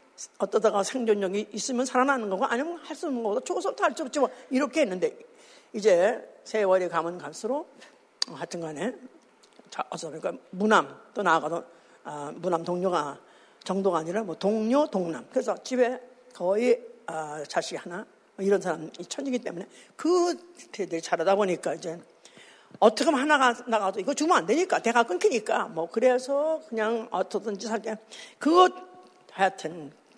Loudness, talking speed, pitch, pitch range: -27 LUFS, 310 characters per minute, 230 Hz, 190-300 Hz